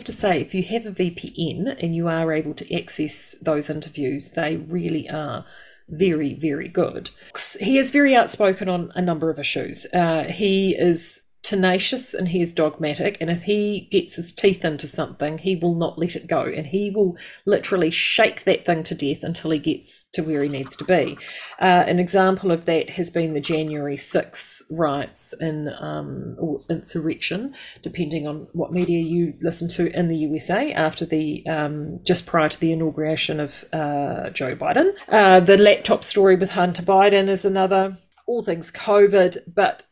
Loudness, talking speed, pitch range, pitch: -21 LUFS, 180 wpm, 155-190 Hz, 170 Hz